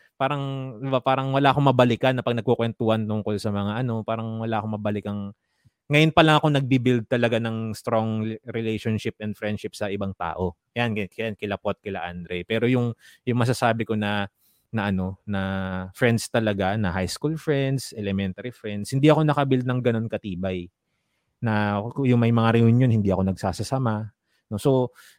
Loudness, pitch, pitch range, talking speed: -24 LUFS, 115 Hz, 105-125 Hz, 175 wpm